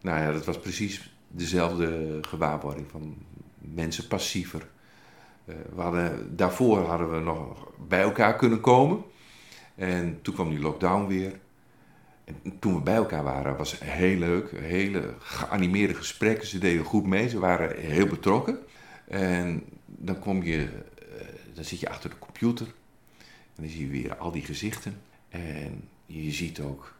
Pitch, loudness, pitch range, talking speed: 90 Hz, -28 LUFS, 80-100 Hz, 155 wpm